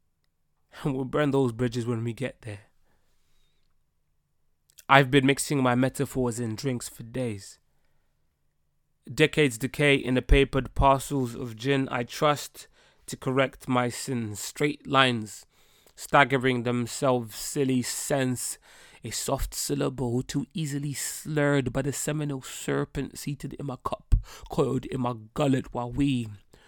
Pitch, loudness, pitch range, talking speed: 130 Hz, -27 LUFS, 115-140 Hz, 130 wpm